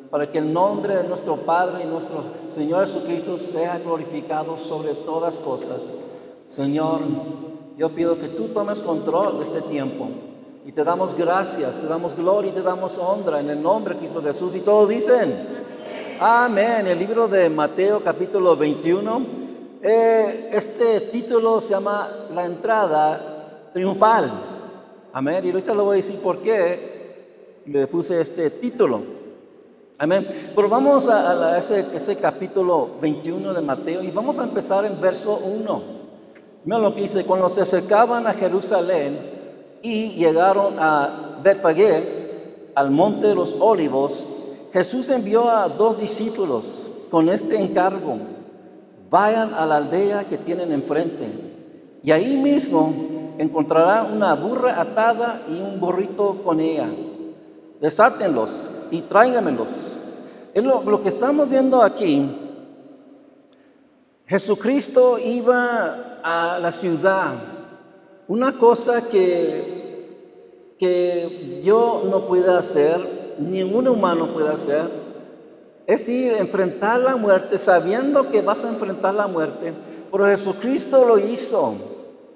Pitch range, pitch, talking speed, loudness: 170-235 Hz, 195 Hz, 130 wpm, -20 LUFS